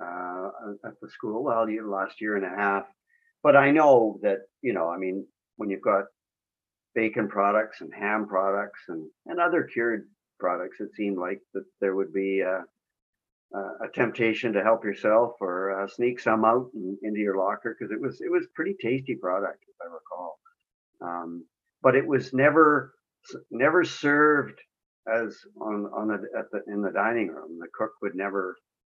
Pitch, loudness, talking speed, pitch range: 105 Hz, -26 LUFS, 180 wpm, 95-130 Hz